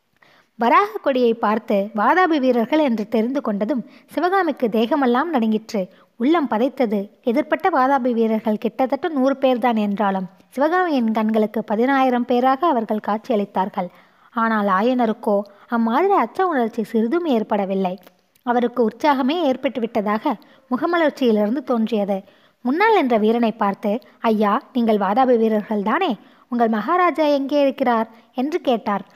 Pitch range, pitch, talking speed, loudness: 215-275 Hz, 235 Hz, 110 wpm, -20 LUFS